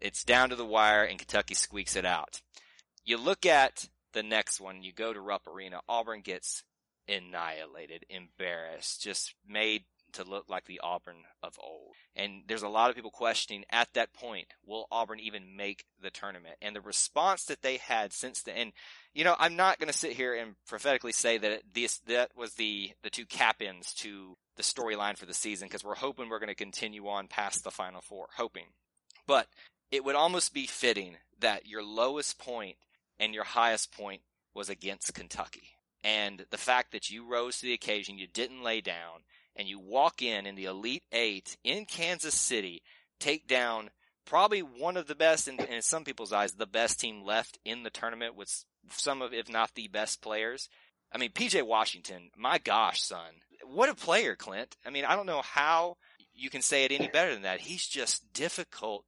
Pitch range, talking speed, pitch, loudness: 100-130 Hz, 195 wpm, 110 Hz, -31 LUFS